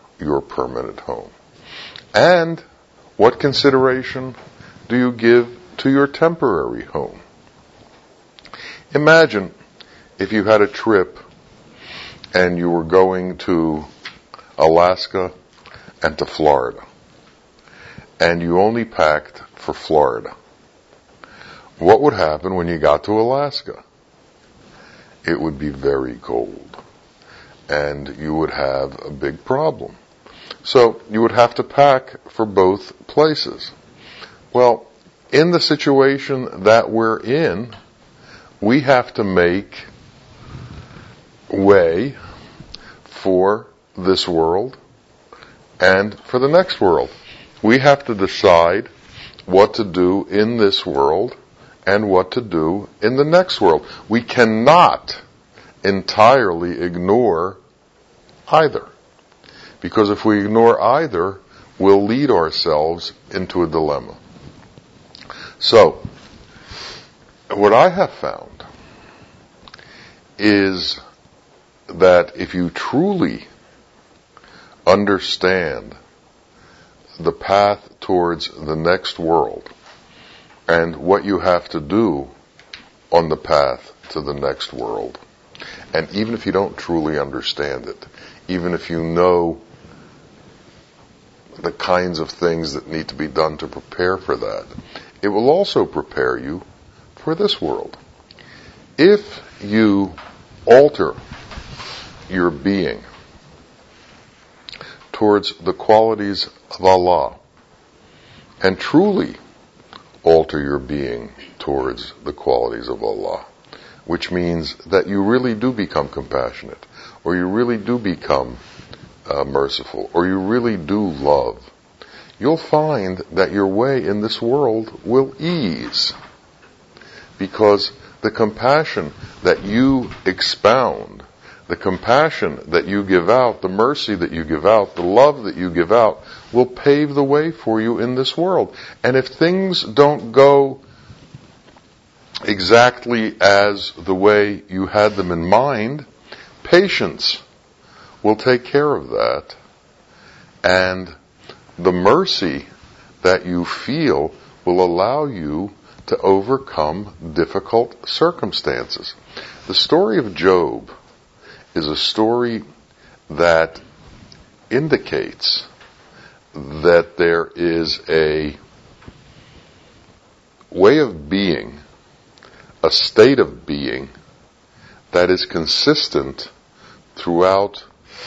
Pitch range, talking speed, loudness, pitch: 85-120 Hz, 110 wpm, -17 LUFS, 100 Hz